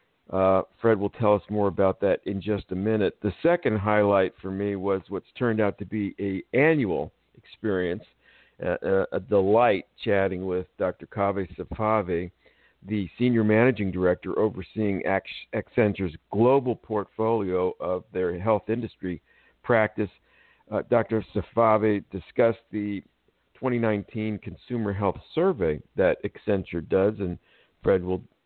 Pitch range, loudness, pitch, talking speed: 95-110 Hz, -26 LUFS, 100 Hz, 135 wpm